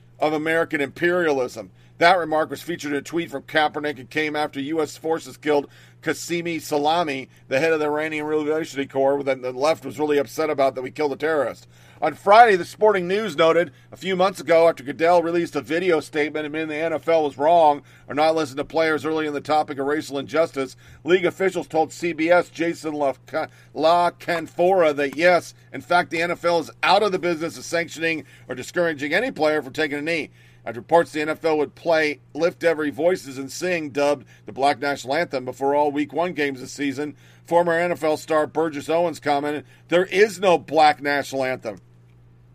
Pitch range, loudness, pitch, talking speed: 140-165 Hz, -22 LUFS, 150 Hz, 190 wpm